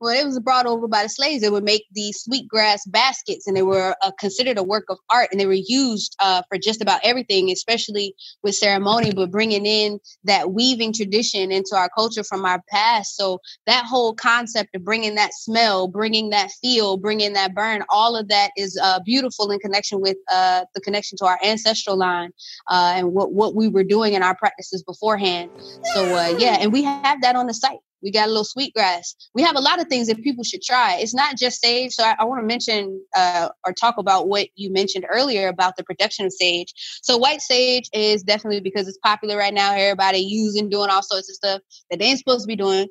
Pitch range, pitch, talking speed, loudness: 195-230 Hz, 210 Hz, 225 wpm, -19 LUFS